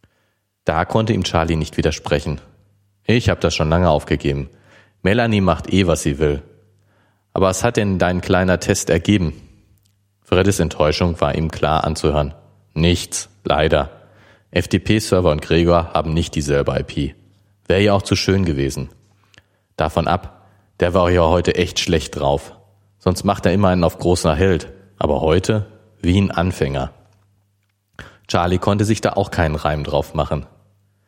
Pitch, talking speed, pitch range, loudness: 95 Hz, 150 wpm, 80-100 Hz, -18 LUFS